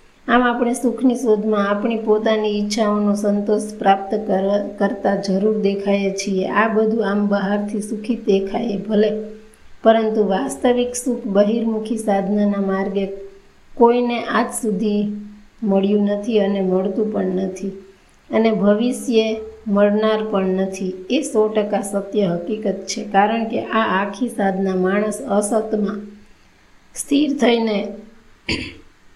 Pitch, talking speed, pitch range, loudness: 210 Hz, 115 wpm, 200-220 Hz, -19 LUFS